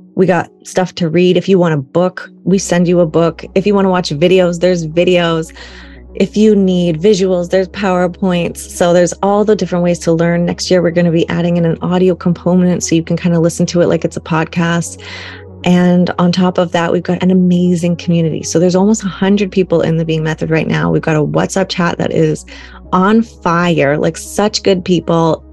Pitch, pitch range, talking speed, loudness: 175 Hz, 170-185 Hz, 220 wpm, -13 LUFS